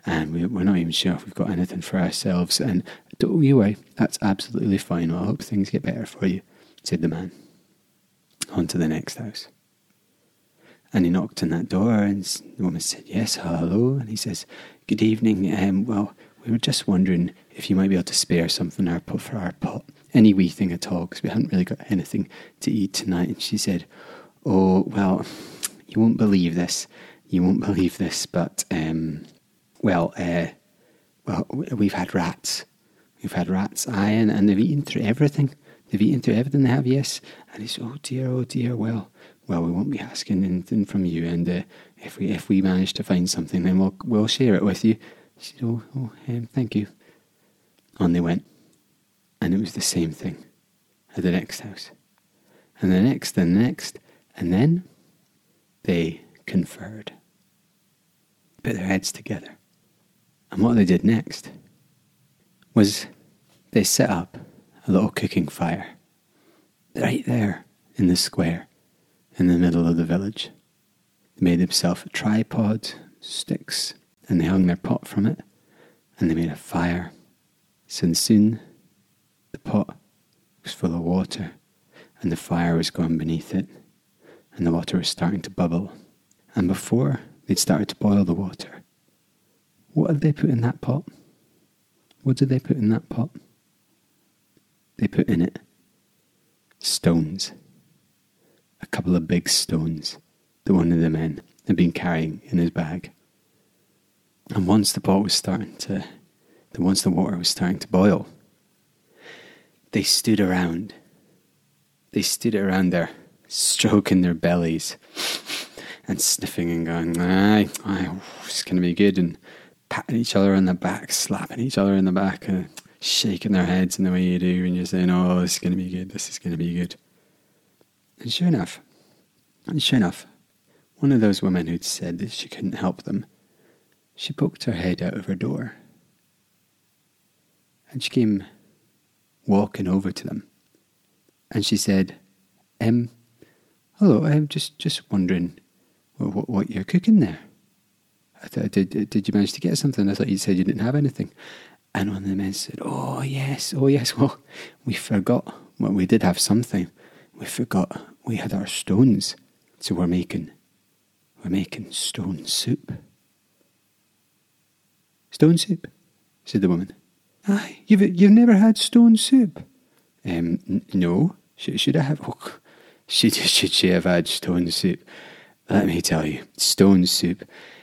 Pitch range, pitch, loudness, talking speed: 90-120 Hz, 100 Hz, -22 LUFS, 170 wpm